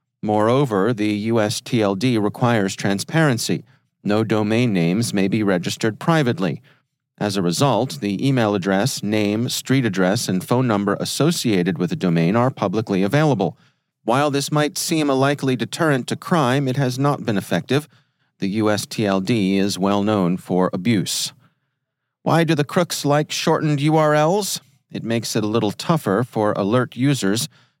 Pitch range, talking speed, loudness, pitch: 100-145 Hz, 145 wpm, -20 LUFS, 120 Hz